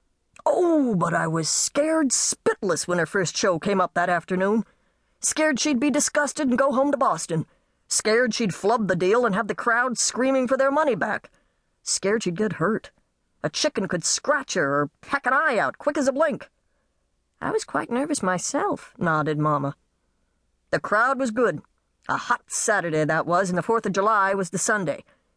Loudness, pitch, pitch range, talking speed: -23 LUFS, 215 Hz, 175-270 Hz, 185 wpm